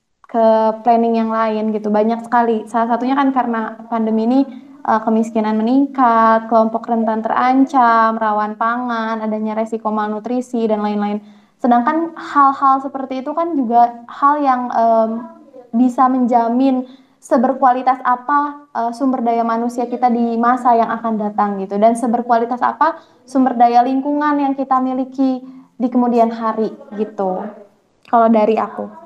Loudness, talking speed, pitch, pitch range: -16 LUFS, 130 wpm, 235 Hz, 225-260 Hz